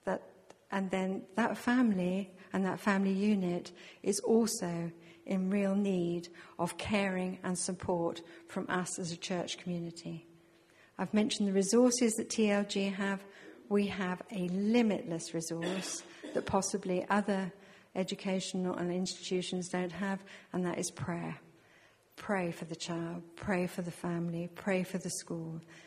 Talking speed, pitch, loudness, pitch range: 135 wpm, 185 Hz, -34 LUFS, 175-200 Hz